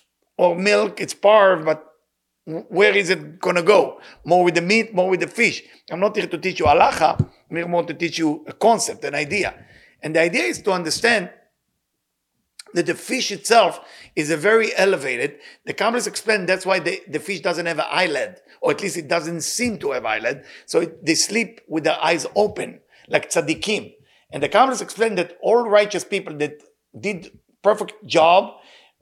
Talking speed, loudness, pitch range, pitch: 190 wpm, -20 LUFS, 170-210 Hz, 185 Hz